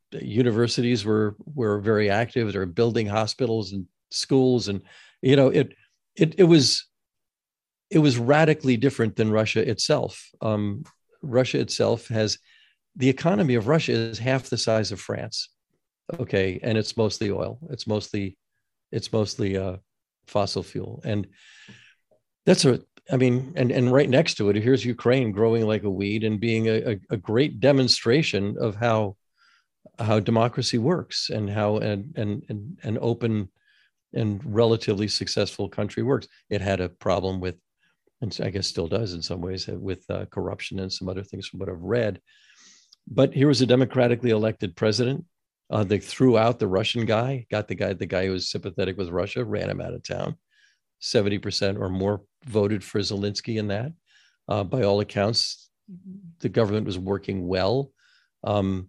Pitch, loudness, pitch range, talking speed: 110 Hz, -24 LUFS, 100-125 Hz, 165 wpm